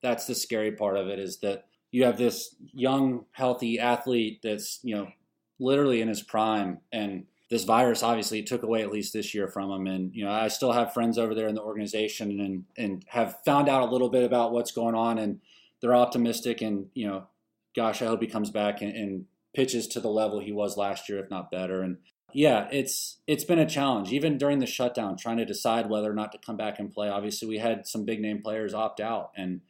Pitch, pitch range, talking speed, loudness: 110 Hz, 105-120 Hz, 230 wpm, -28 LUFS